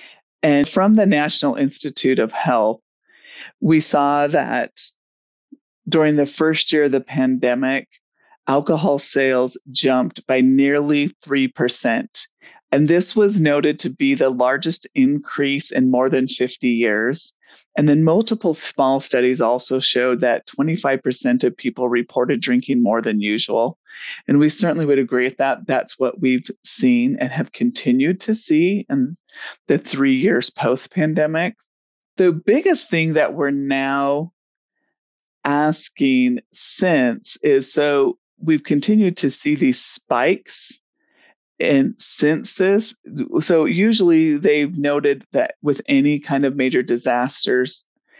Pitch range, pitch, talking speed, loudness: 135-220 Hz, 150 Hz, 130 wpm, -18 LUFS